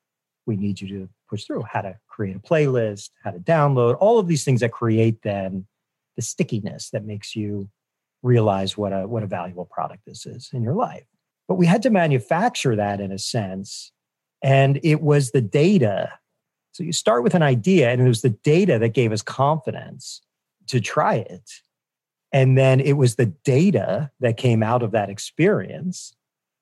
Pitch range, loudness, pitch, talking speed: 105-145 Hz, -21 LUFS, 125 Hz, 185 wpm